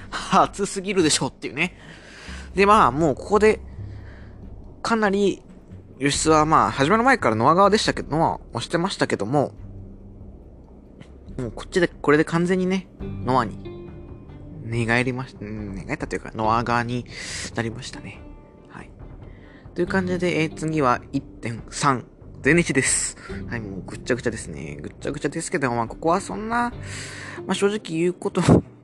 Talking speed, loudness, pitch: 310 characters per minute, -22 LUFS, 130 Hz